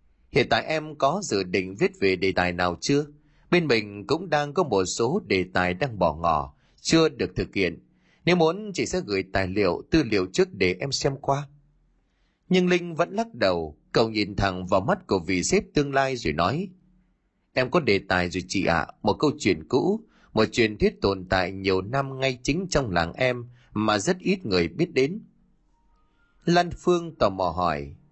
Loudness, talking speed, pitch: -25 LUFS, 200 wpm, 135 Hz